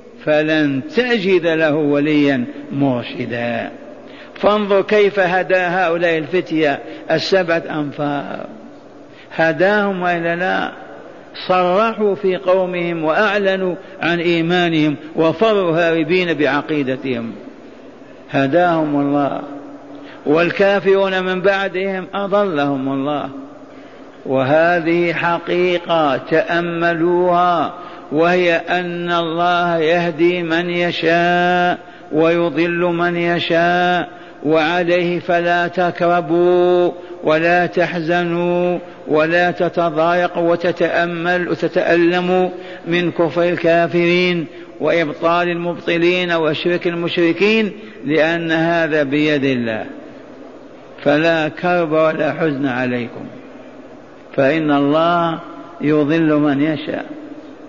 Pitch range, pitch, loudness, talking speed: 160-180 Hz, 170 Hz, -16 LUFS, 75 wpm